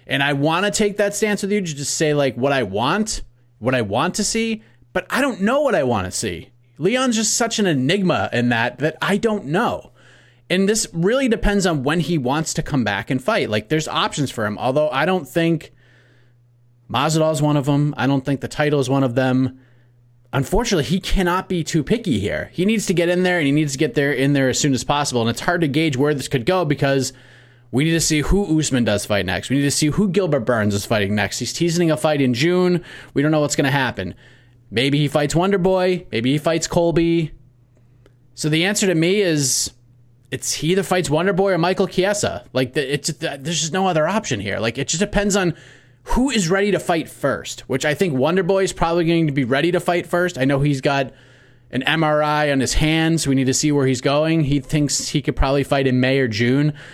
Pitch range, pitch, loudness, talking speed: 130-175 Hz, 150 Hz, -19 LUFS, 240 wpm